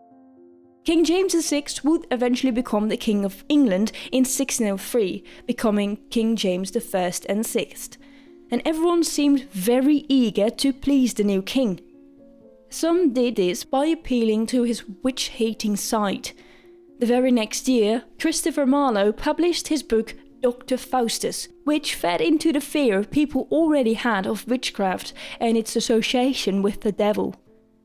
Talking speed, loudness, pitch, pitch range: 140 wpm, -22 LUFS, 250 Hz, 220-285 Hz